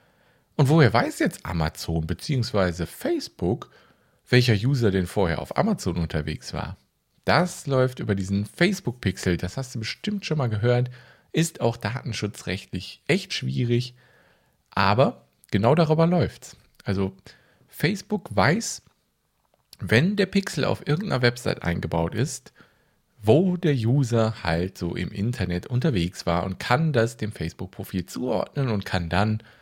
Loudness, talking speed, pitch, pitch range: -24 LUFS, 130 wpm, 115 Hz, 95-135 Hz